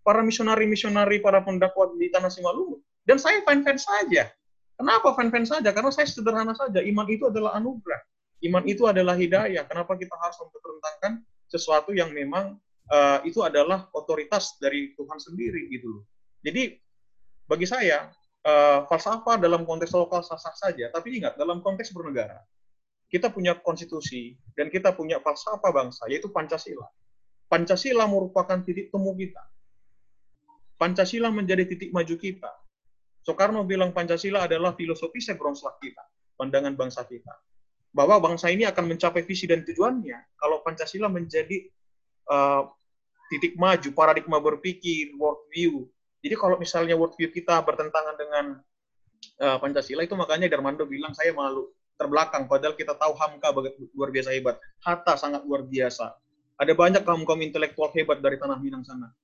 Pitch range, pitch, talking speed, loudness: 145-200 Hz, 170 Hz, 145 wpm, -25 LUFS